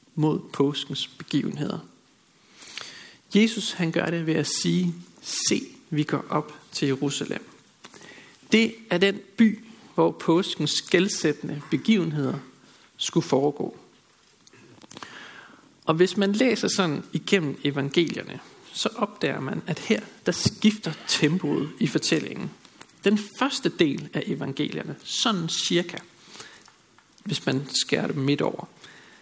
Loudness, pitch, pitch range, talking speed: -25 LUFS, 170 Hz, 150-200 Hz, 115 wpm